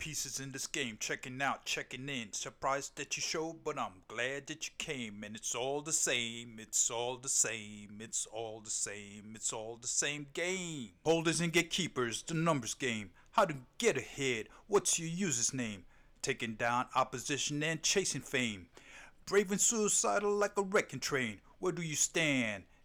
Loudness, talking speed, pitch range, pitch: -34 LUFS, 175 wpm, 115-160 Hz, 135 Hz